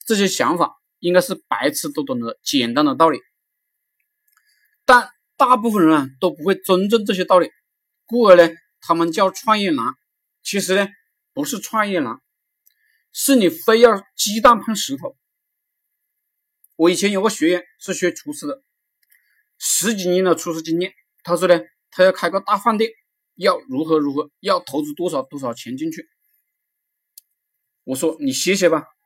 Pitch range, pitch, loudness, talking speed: 175-260 Hz, 195 Hz, -18 LUFS, 225 characters per minute